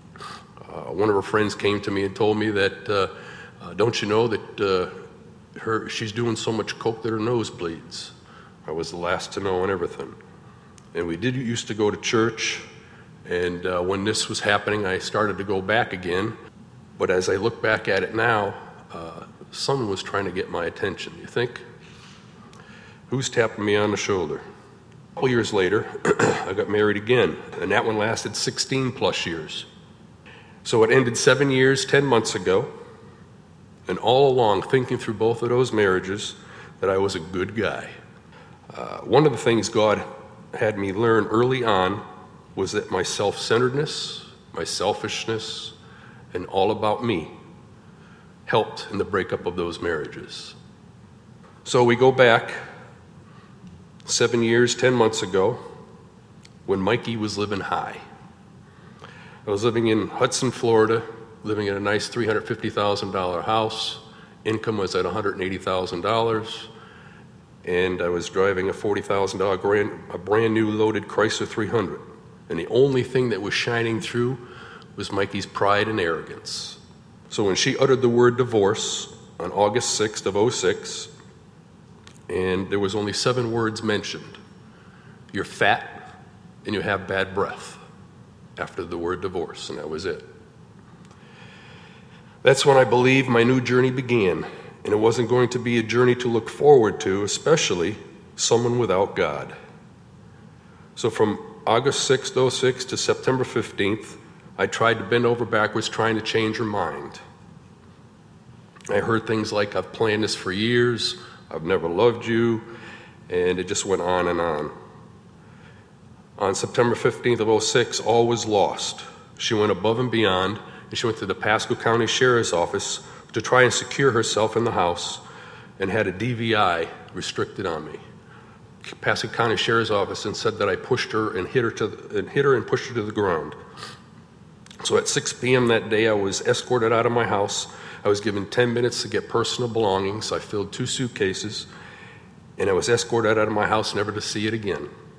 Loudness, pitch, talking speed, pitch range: -23 LUFS, 115 Hz, 170 wpm, 105-120 Hz